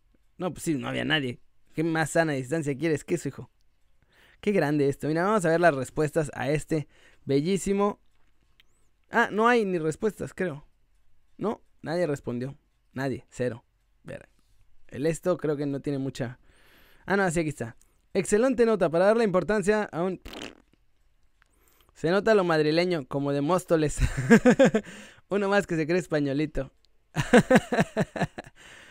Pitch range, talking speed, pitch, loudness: 135-190 Hz, 145 wpm, 155 Hz, -26 LUFS